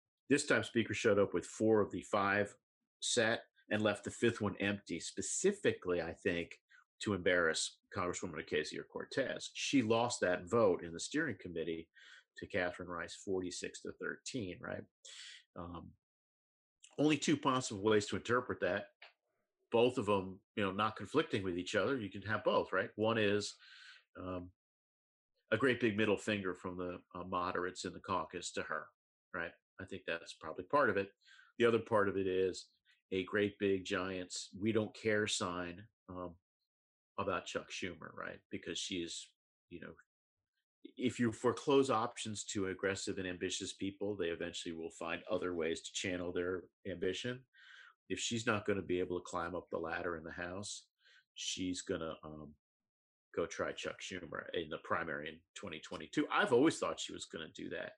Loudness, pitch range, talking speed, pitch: -37 LUFS, 90-110 Hz, 175 wpm, 100 Hz